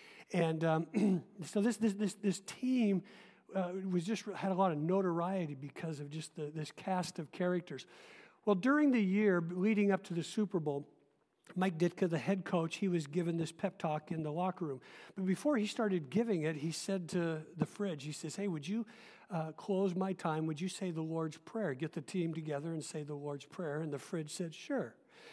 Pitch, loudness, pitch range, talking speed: 180 Hz, -37 LUFS, 160-200 Hz, 210 wpm